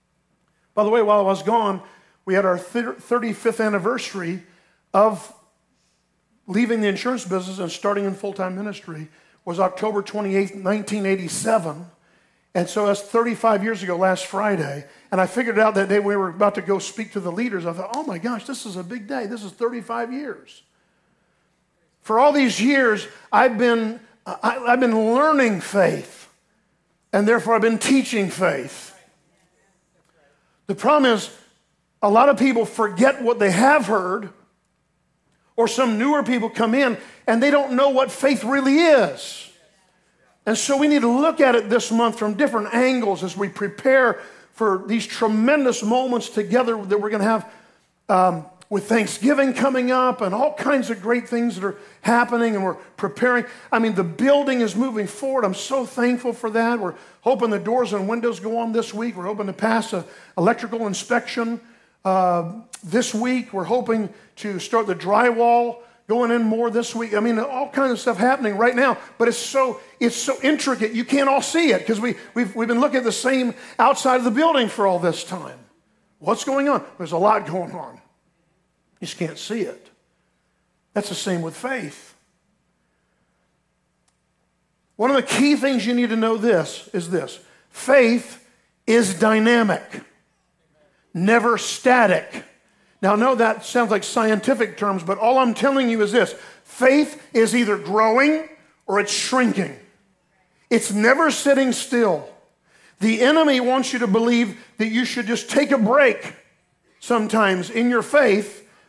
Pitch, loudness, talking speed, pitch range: 225 Hz, -20 LUFS, 170 wpm, 200-245 Hz